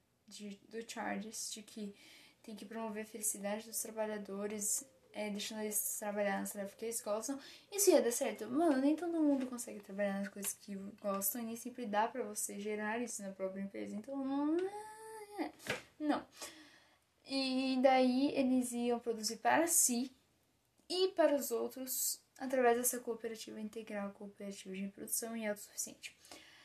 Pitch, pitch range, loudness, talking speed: 230 Hz, 210-270 Hz, -37 LUFS, 150 wpm